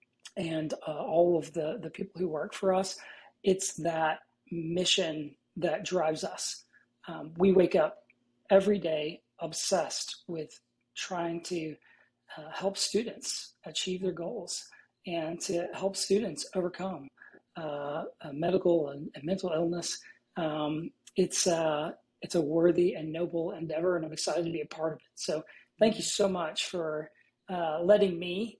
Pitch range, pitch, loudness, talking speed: 155-190 Hz, 170 Hz, -31 LUFS, 145 wpm